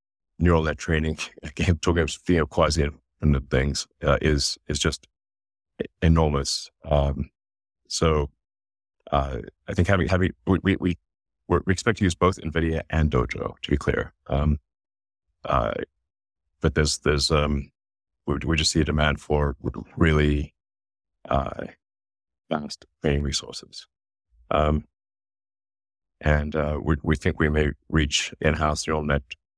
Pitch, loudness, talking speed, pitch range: 75 Hz, -24 LUFS, 140 wpm, 70-85 Hz